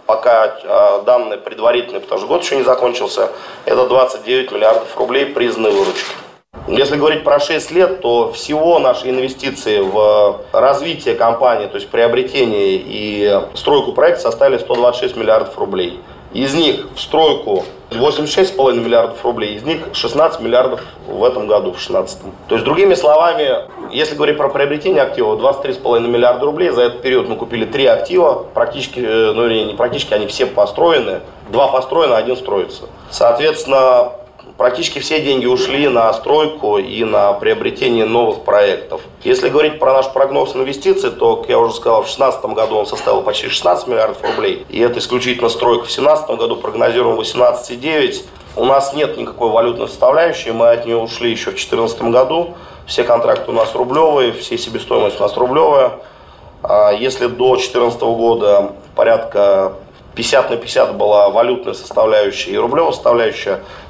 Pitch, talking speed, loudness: 150 Hz, 150 wpm, -14 LUFS